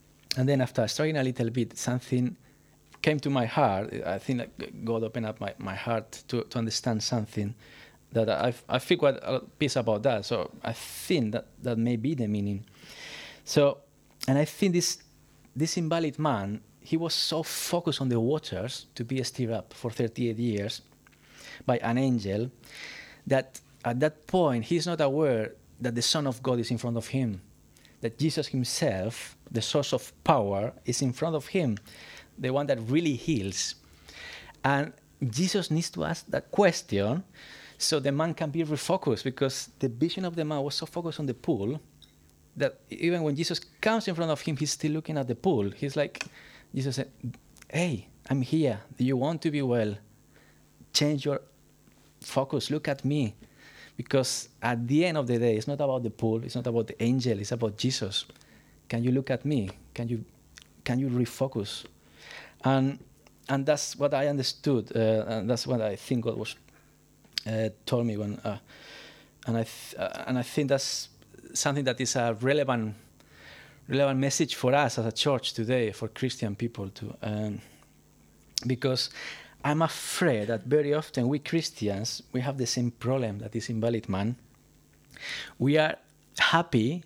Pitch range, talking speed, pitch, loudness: 115-145 Hz, 175 wpm, 130 Hz, -29 LUFS